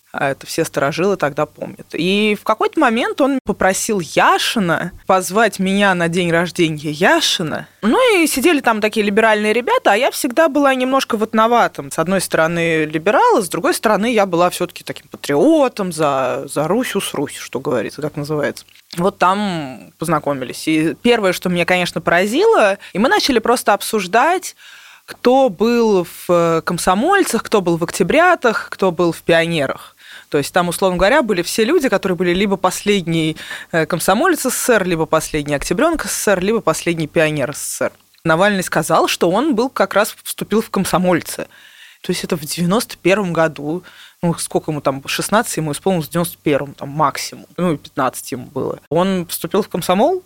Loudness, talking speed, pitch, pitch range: -16 LUFS, 165 wpm, 185 Hz, 165-225 Hz